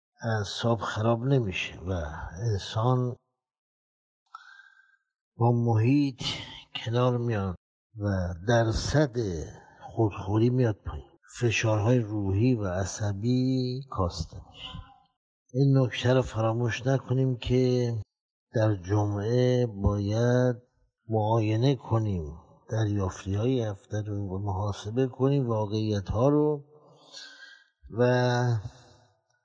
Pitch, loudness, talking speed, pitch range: 120 Hz, -27 LUFS, 85 wpm, 105-125 Hz